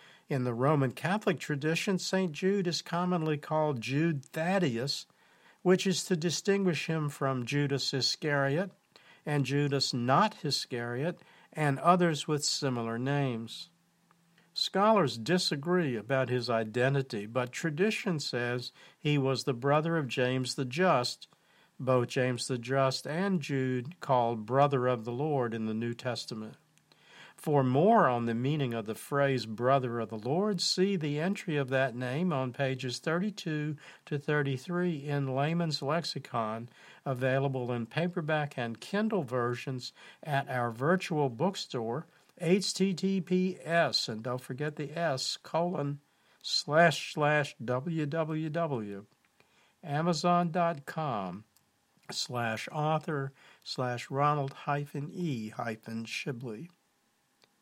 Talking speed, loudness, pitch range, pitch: 120 wpm, -31 LUFS, 130-170 Hz, 145 Hz